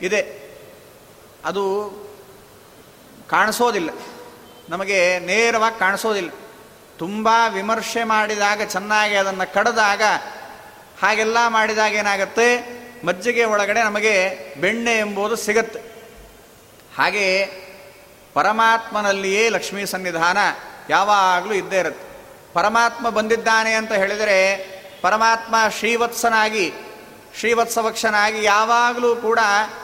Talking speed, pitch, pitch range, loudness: 75 wpm, 210 Hz, 195-225 Hz, -18 LUFS